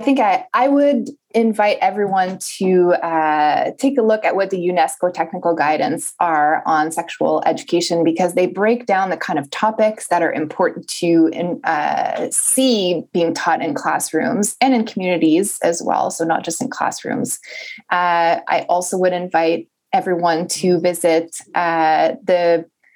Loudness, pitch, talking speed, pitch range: -17 LUFS, 180 Hz, 160 wpm, 170-220 Hz